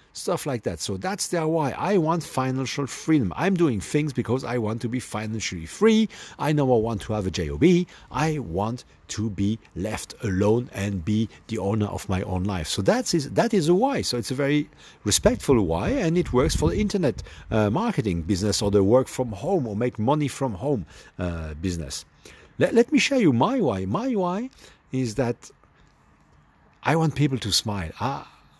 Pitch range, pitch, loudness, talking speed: 100-160 Hz, 125 Hz, -24 LUFS, 195 wpm